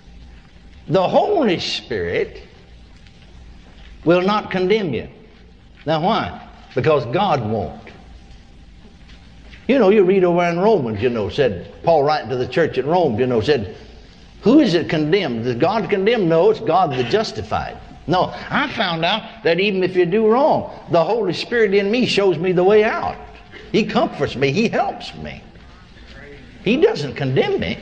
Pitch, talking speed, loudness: 180 Hz, 160 wpm, -18 LUFS